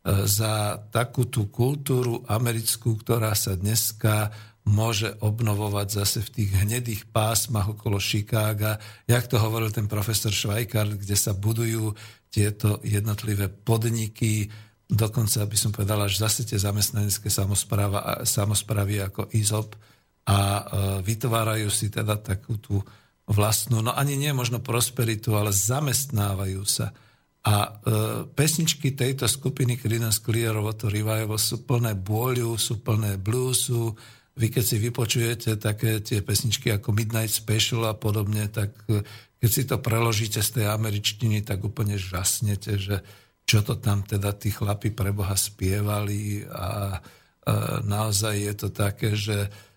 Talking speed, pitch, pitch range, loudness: 135 wpm, 110 Hz, 105-115 Hz, -25 LUFS